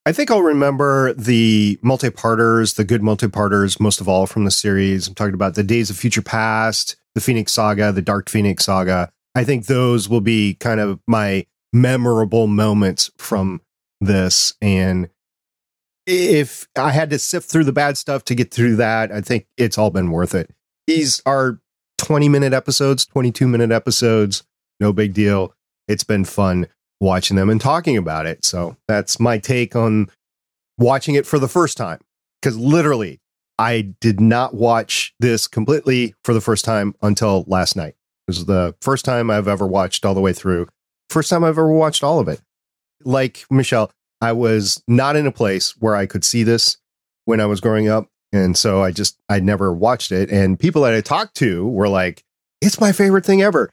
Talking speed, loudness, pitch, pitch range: 185 wpm, -17 LUFS, 110 Hz, 95-125 Hz